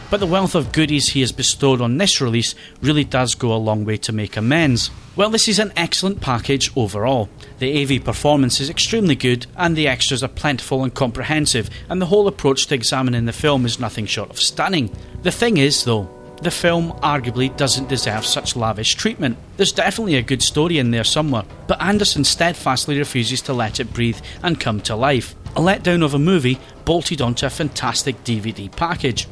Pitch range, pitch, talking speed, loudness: 120-155 Hz, 135 Hz, 195 wpm, -18 LUFS